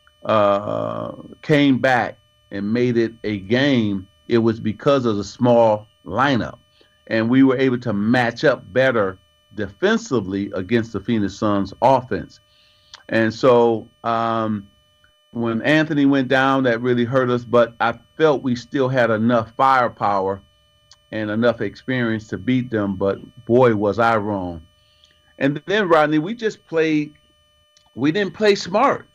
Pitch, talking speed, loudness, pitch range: 115 Hz, 140 wpm, -19 LUFS, 100-130 Hz